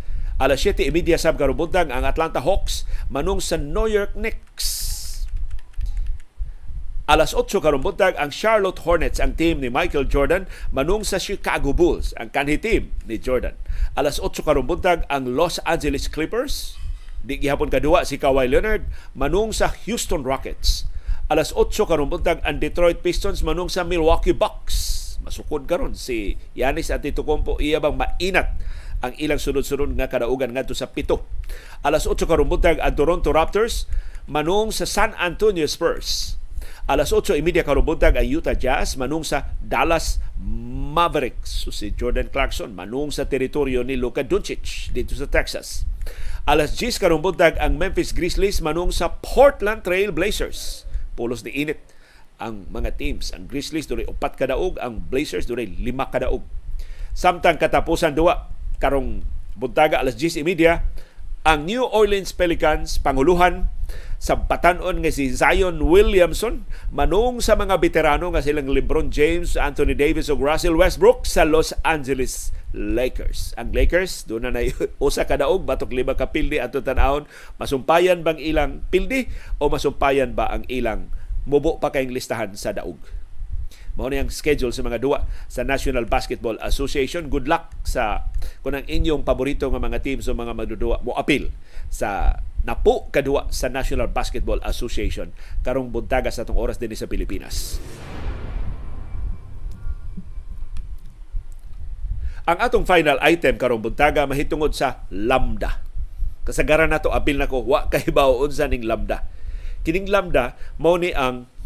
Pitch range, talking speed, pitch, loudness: 115-170 Hz, 145 wpm, 145 Hz, -22 LUFS